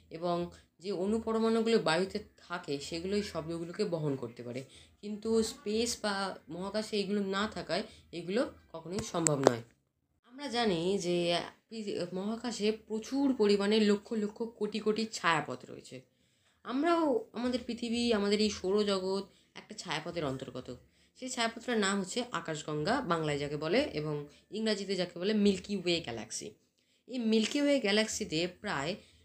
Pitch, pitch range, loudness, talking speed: 205 Hz, 170-225 Hz, -33 LUFS, 125 wpm